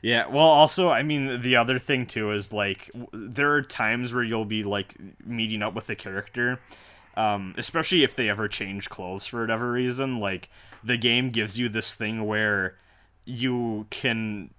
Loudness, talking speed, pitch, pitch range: -25 LUFS, 175 wpm, 115 Hz, 105-125 Hz